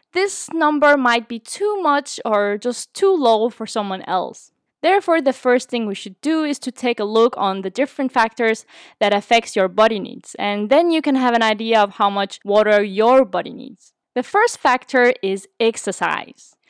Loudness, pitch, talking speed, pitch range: -18 LUFS, 235 Hz, 190 wpm, 210-285 Hz